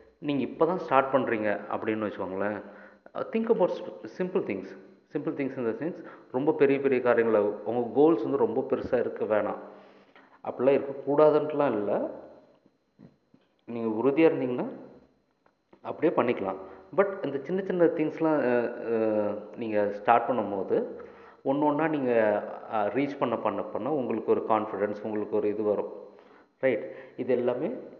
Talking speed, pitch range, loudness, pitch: 130 wpm, 110-160 Hz, -28 LUFS, 135 Hz